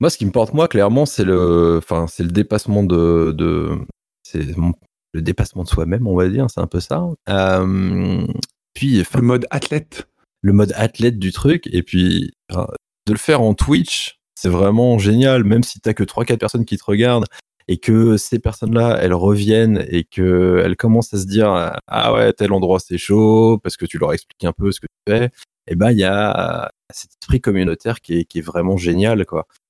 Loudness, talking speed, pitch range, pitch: -17 LUFS, 205 wpm, 90-115 Hz, 100 Hz